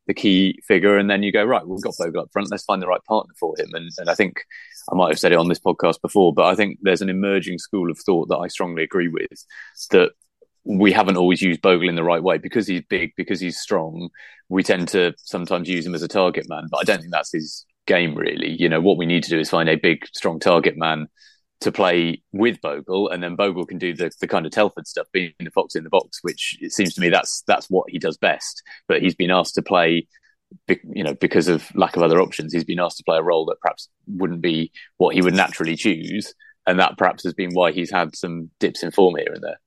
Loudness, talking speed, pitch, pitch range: -20 LUFS, 260 wpm, 95 Hz, 85-100 Hz